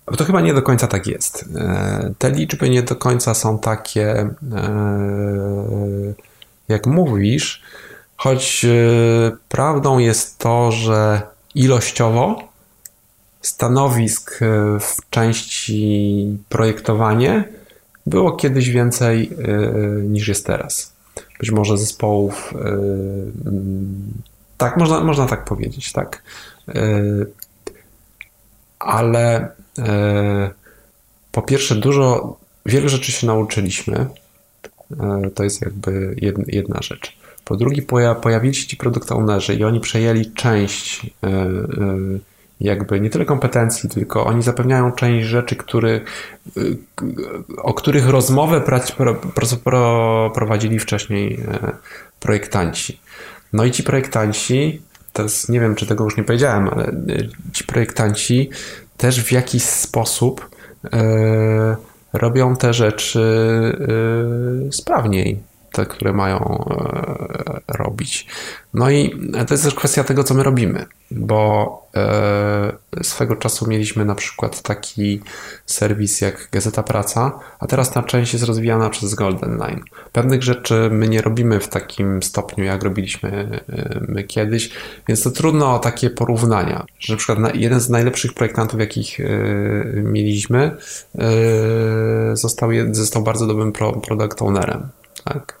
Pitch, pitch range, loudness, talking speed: 110 Hz, 105-125 Hz, -18 LUFS, 110 wpm